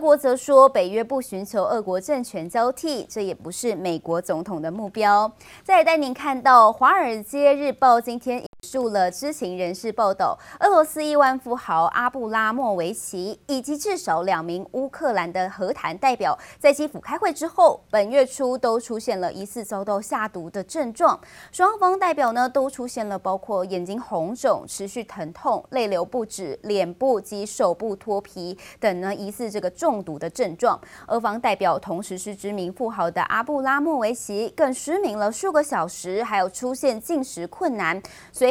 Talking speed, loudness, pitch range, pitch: 270 characters per minute, -22 LUFS, 195-275 Hz, 230 Hz